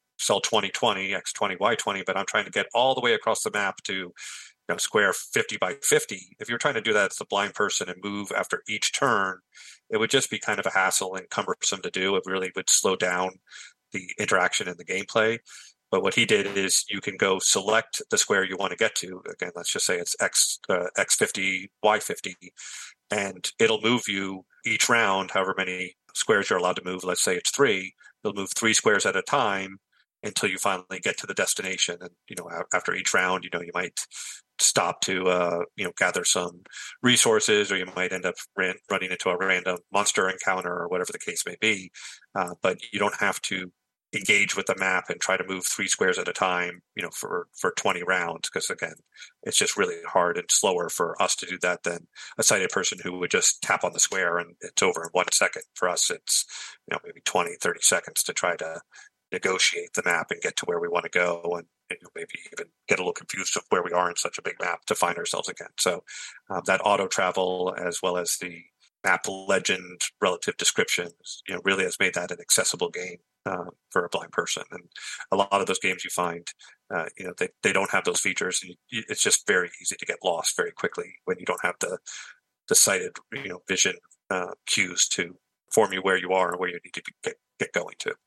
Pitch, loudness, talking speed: 110 Hz, -25 LUFS, 230 wpm